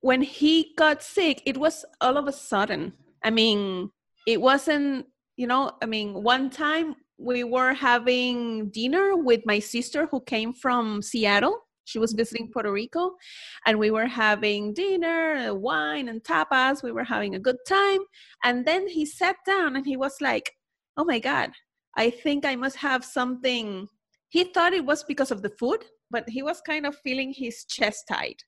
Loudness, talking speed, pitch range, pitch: -25 LUFS, 180 wpm, 230-310 Hz, 260 Hz